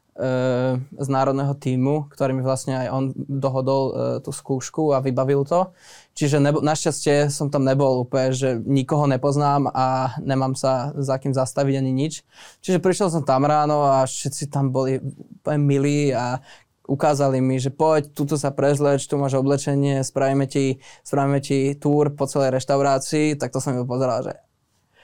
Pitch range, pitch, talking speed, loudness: 130-145 Hz, 140 Hz, 160 wpm, -21 LUFS